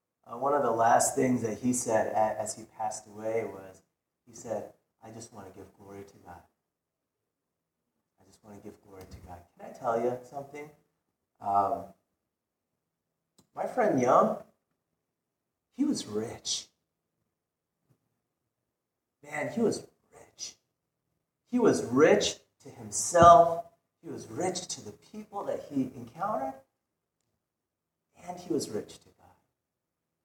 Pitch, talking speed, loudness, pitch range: 110 Hz, 135 wpm, -28 LUFS, 100-135 Hz